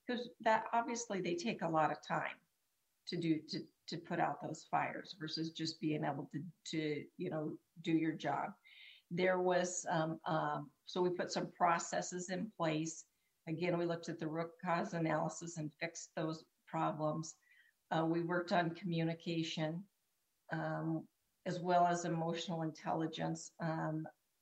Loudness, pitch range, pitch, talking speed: -39 LUFS, 155-175 Hz, 165 Hz, 155 wpm